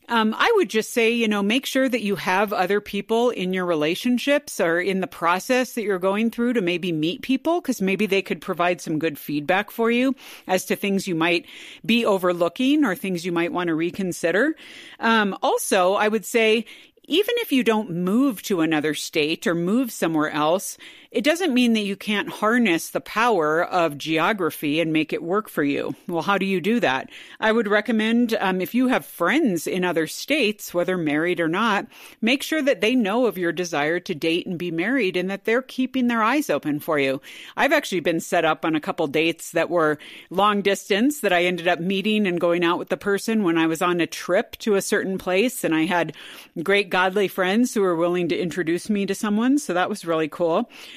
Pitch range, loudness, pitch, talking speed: 170-230 Hz, -22 LUFS, 195 Hz, 215 wpm